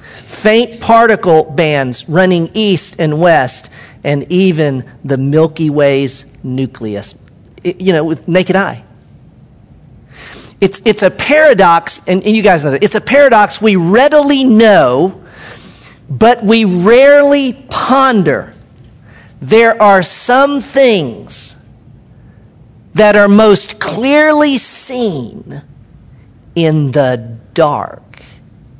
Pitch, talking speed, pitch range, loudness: 190 Hz, 105 wpm, 150-225 Hz, -10 LUFS